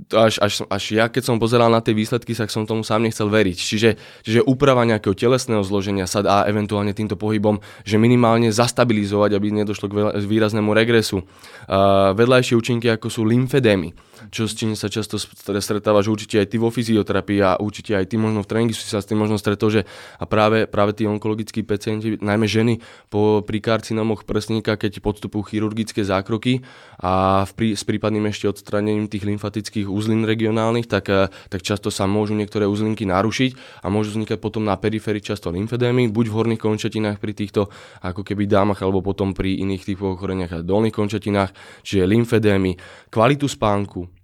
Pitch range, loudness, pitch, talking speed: 100-110 Hz, -20 LUFS, 105 Hz, 180 wpm